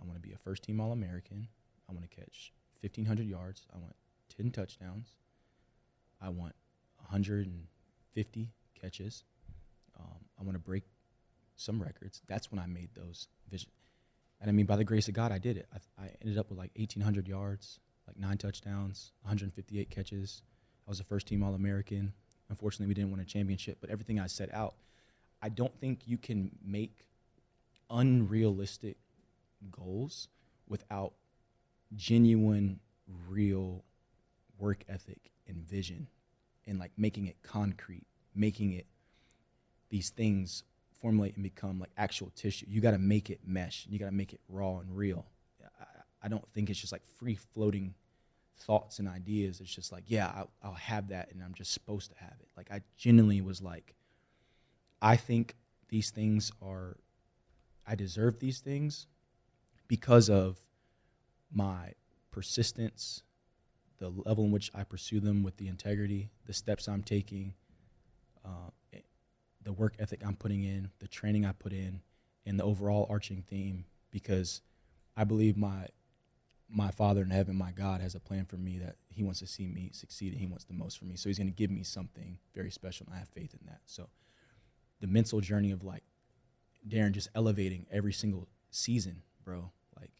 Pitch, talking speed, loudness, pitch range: 100 Hz, 170 wpm, -35 LUFS, 95-110 Hz